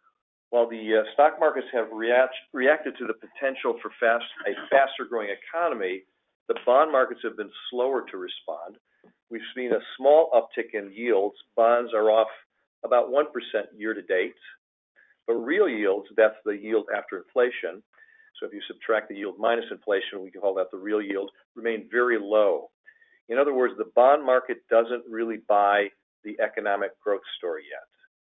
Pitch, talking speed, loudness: 155 Hz, 170 wpm, -25 LUFS